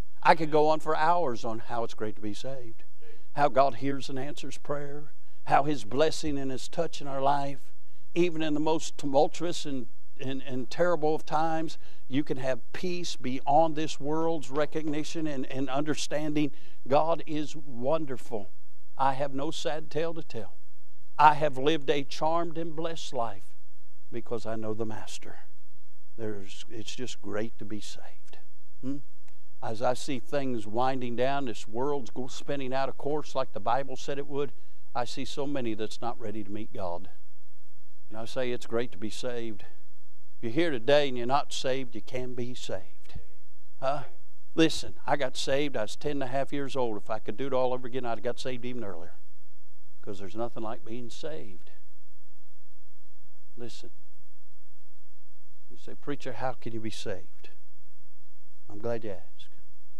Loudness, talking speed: -31 LUFS, 175 wpm